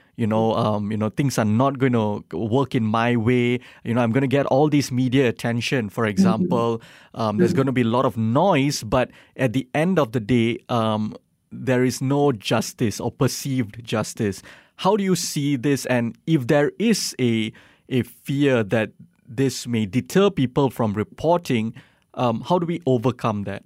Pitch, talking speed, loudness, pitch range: 125 Hz, 190 wpm, -22 LUFS, 115-145 Hz